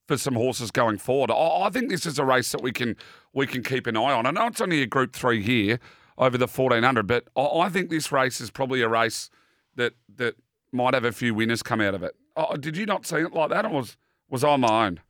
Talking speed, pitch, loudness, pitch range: 260 wpm, 130 Hz, -24 LUFS, 120-150 Hz